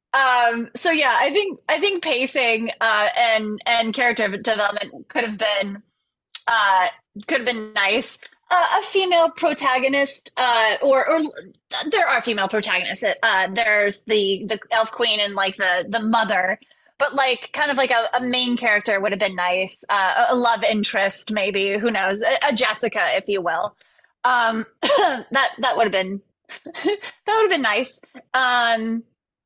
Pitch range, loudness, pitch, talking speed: 210-275 Hz, -19 LUFS, 235 Hz, 165 wpm